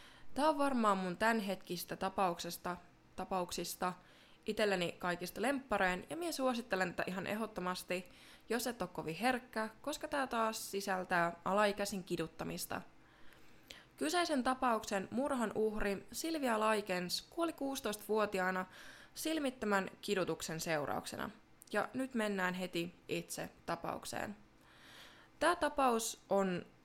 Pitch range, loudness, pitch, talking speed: 180-250 Hz, -38 LUFS, 205 Hz, 105 wpm